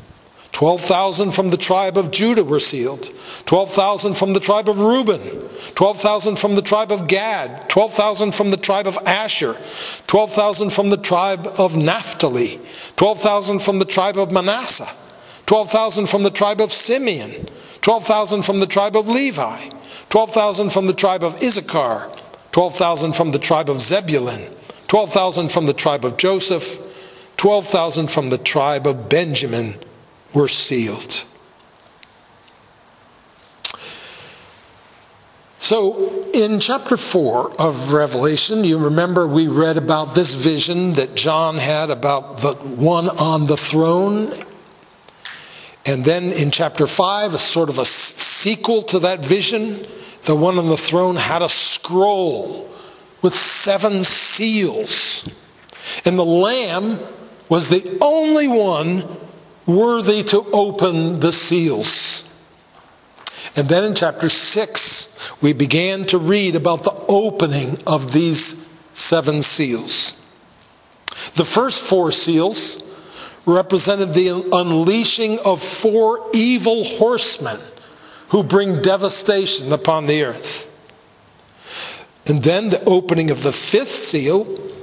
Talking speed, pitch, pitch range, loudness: 125 wpm, 190 Hz, 160-210 Hz, -16 LUFS